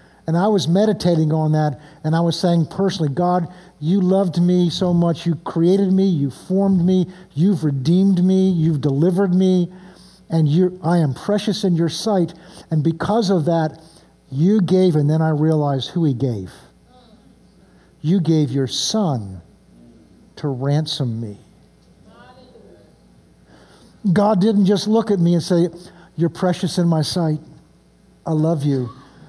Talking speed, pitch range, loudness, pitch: 150 wpm, 155-185 Hz, -18 LUFS, 170 Hz